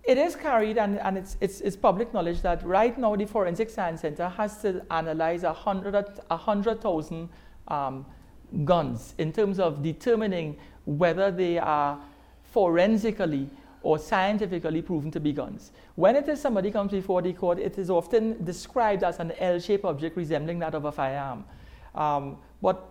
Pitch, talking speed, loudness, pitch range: 175 Hz, 160 wpm, -27 LUFS, 155-205 Hz